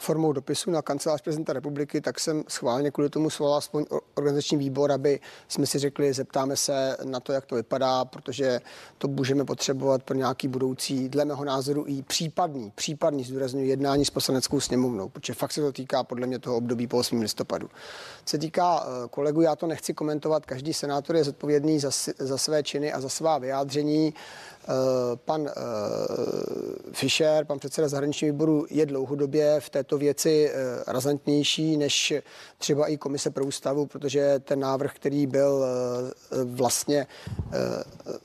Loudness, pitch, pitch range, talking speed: -27 LUFS, 145 Hz, 135-150 Hz, 160 wpm